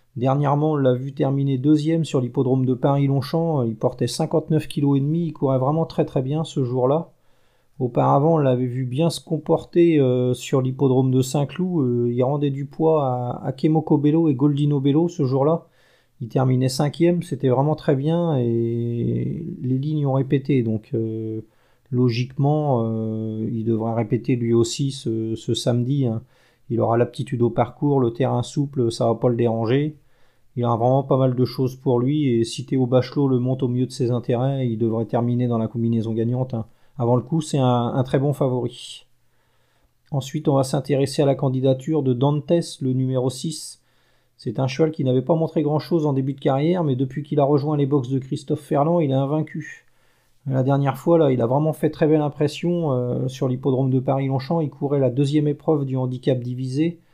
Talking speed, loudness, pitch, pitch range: 195 wpm, -21 LUFS, 135 Hz, 125-150 Hz